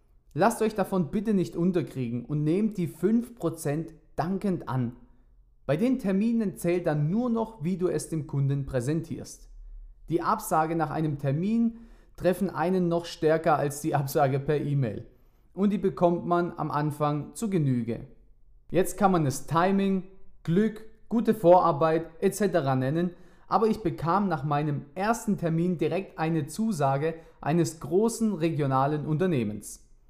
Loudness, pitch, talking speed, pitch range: -27 LUFS, 165 Hz, 140 wpm, 145-190 Hz